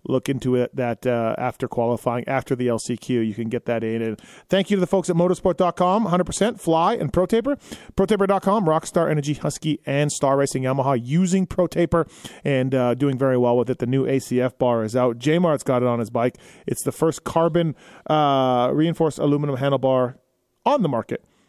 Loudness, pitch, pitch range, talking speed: -21 LUFS, 140 Hz, 125-170 Hz, 190 wpm